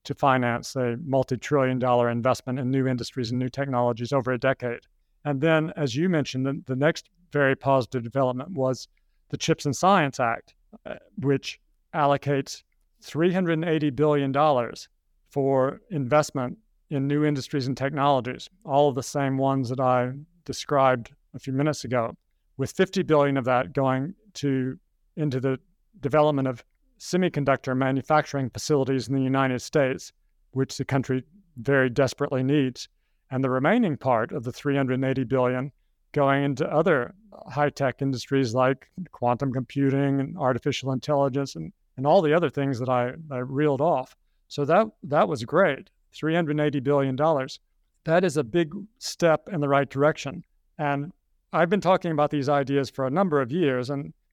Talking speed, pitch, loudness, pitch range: 155 wpm, 140 Hz, -25 LUFS, 130-150 Hz